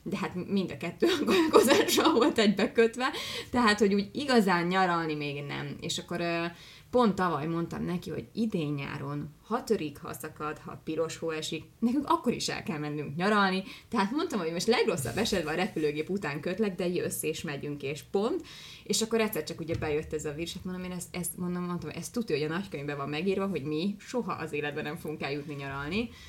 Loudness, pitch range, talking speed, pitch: -30 LUFS, 155-210 Hz, 200 wpm, 175 Hz